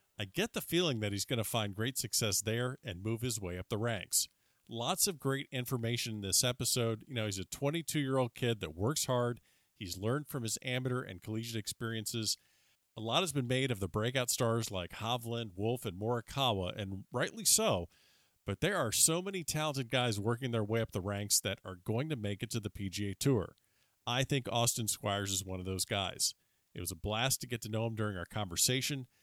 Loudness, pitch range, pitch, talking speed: -34 LUFS, 105-130 Hz, 115 Hz, 215 wpm